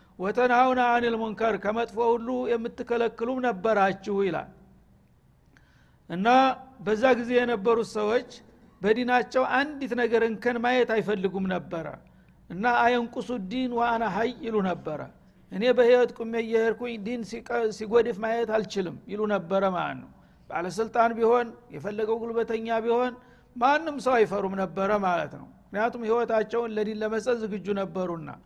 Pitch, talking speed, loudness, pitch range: 230 Hz, 120 wpm, -26 LUFS, 210-245 Hz